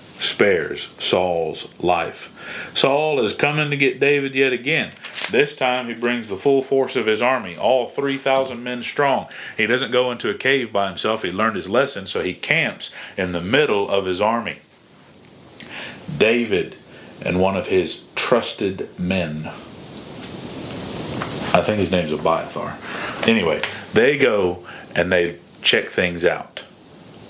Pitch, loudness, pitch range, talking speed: 120 Hz, -20 LUFS, 100-135 Hz, 145 wpm